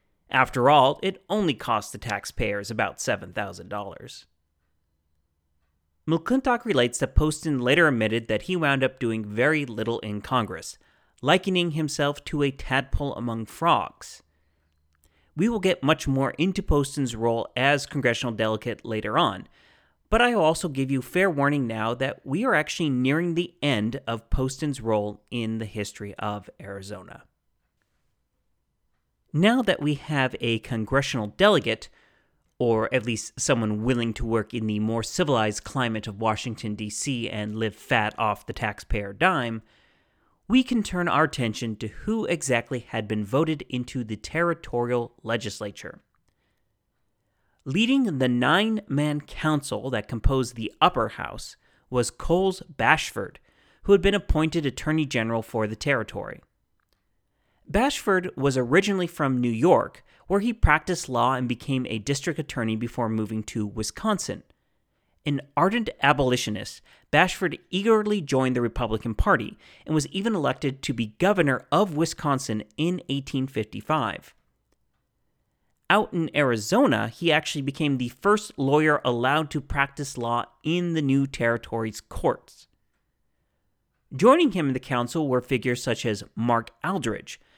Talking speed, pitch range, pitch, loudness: 140 wpm, 110-155 Hz, 130 Hz, -25 LUFS